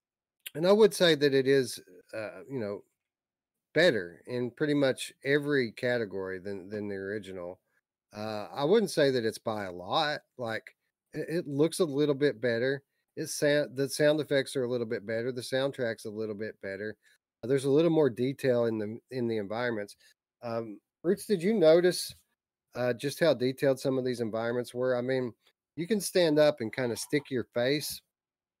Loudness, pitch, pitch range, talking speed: -29 LUFS, 130 Hz, 115-145 Hz, 185 wpm